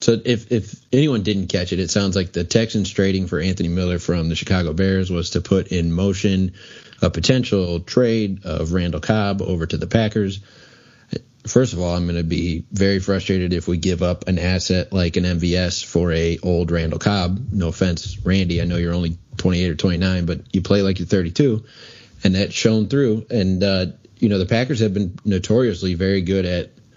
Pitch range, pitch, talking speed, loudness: 90-105 Hz, 95 Hz, 205 wpm, -20 LUFS